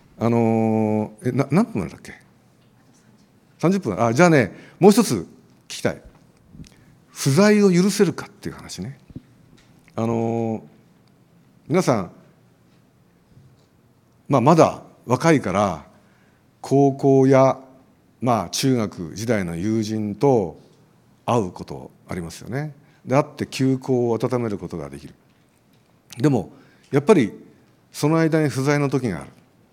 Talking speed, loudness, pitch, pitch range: 220 characters per minute, -20 LUFS, 130 Hz, 110-145 Hz